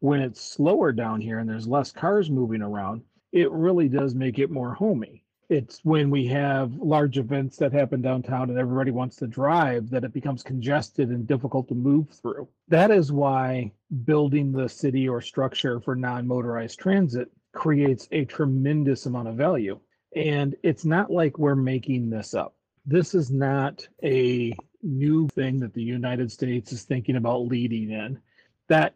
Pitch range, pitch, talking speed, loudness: 125-145 Hz, 135 Hz, 170 wpm, -25 LUFS